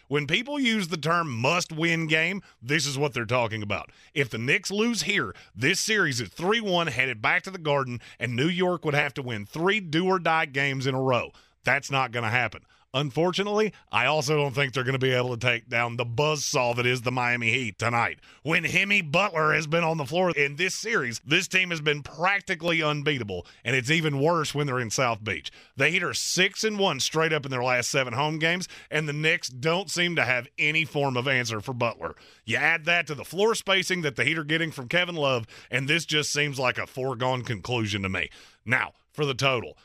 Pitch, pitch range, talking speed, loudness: 145 Hz, 125-170 Hz, 230 wpm, -25 LUFS